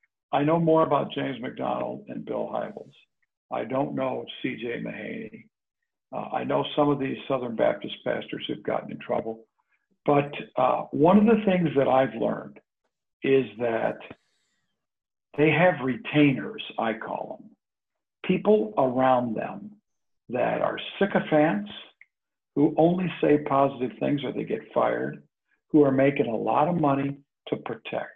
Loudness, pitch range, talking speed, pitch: -25 LUFS, 130-170 Hz, 145 wpm, 145 Hz